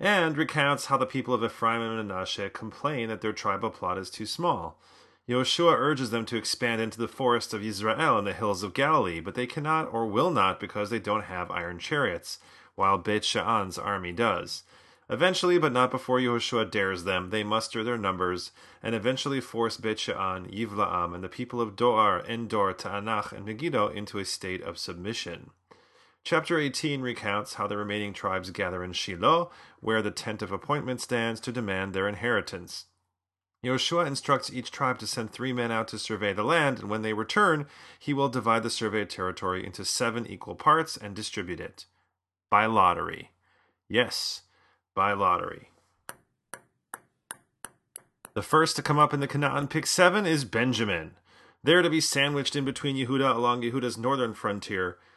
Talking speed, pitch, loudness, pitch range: 170 wpm, 115 Hz, -28 LUFS, 105-135 Hz